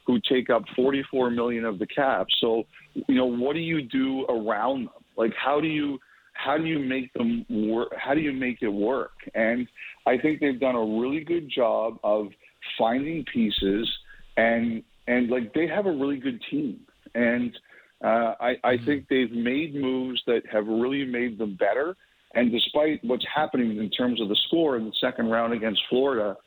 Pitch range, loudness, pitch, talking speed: 115-145 Hz, -26 LUFS, 125 Hz, 190 wpm